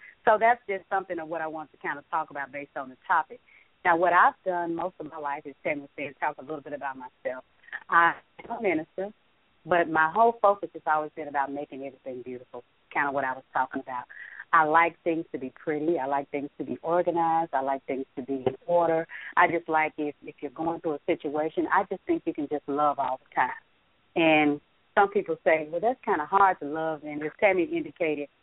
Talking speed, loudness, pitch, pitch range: 230 wpm, -27 LUFS, 160 Hz, 145-175 Hz